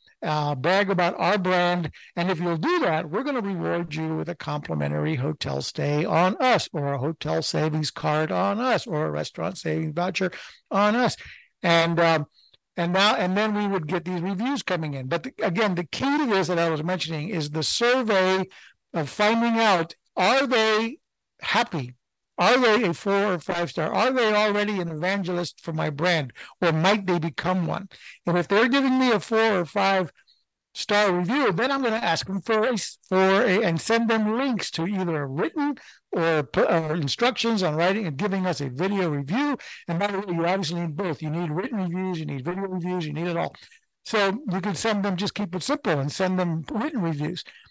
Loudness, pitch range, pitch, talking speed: -24 LUFS, 165-210 Hz, 185 Hz, 205 wpm